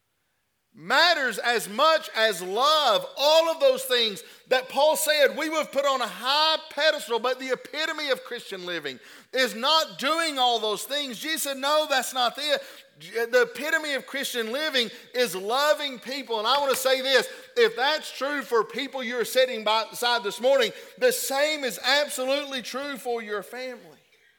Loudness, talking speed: -24 LUFS, 175 wpm